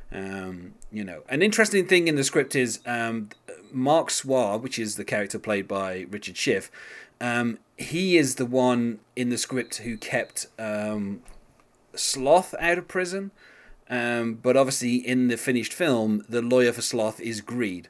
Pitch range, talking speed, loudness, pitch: 110-130 Hz, 165 wpm, -25 LUFS, 120 Hz